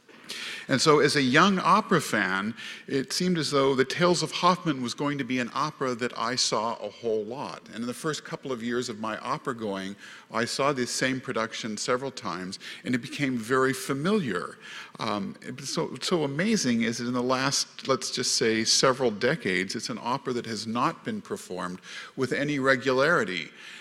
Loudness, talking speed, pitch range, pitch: -27 LUFS, 190 wpm, 120-155 Hz, 130 Hz